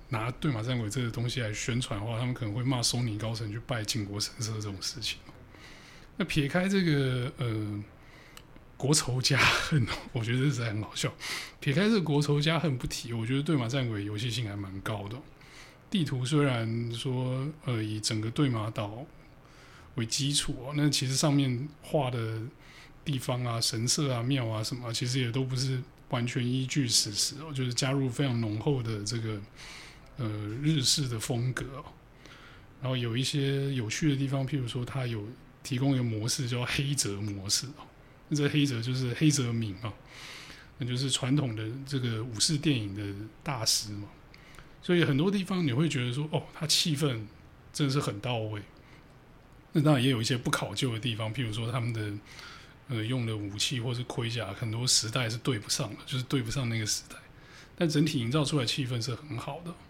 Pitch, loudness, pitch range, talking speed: 130 Hz, -30 LUFS, 115-145 Hz, 275 characters per minute